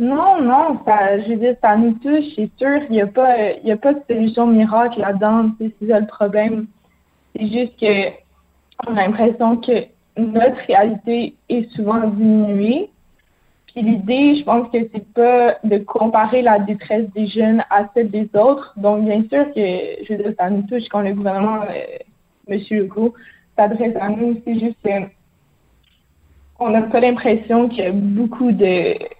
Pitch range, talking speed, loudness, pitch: 210-240 Hz, 170 wpm, -17 LUFS, 220 Hz